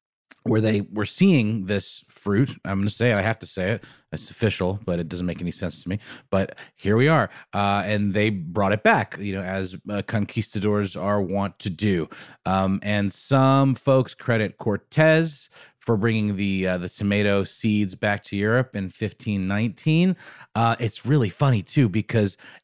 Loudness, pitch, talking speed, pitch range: -23 LUFS, 105 Hz, 185 wpm, 100-115 Hz